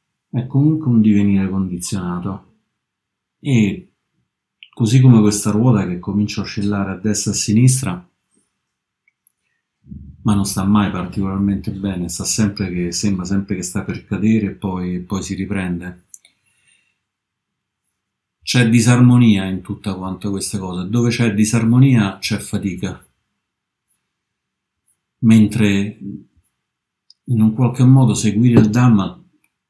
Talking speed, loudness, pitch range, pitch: 120 wpm, -16 LUFS, 95-115 Hz, 105 Hz